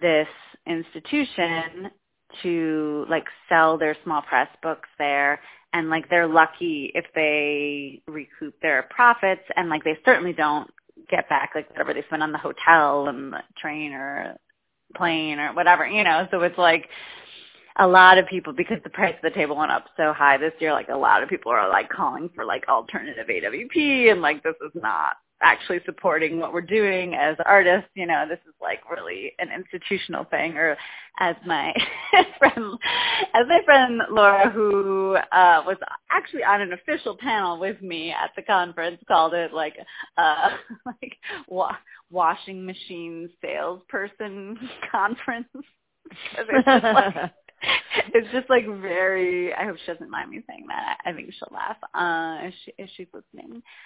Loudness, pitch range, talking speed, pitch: -21 LUFS, 160-210 Hz, 170 wpm, 180 Hz